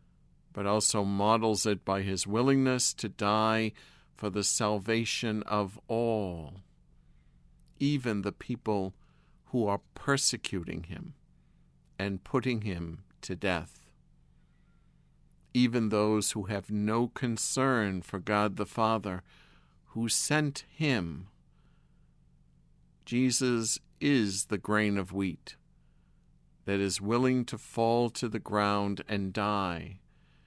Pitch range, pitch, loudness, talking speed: 100-120 Hz, 105 Hz, -30 LUFS, 110 wpm